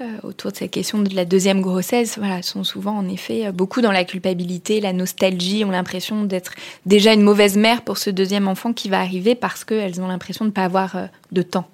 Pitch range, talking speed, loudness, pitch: 185-215 Hz, 220 wpm, -19 LUFS, 195 Hz